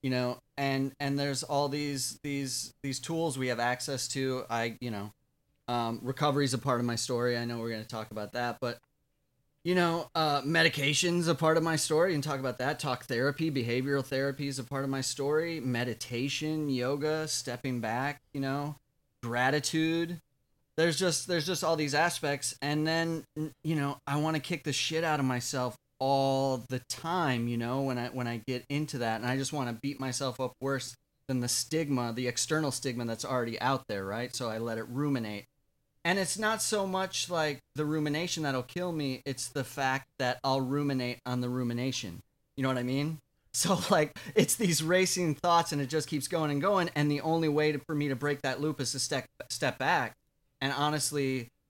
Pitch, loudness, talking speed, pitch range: 140 Hz, -31 LUFS, 205 wpm, 125-155 Hz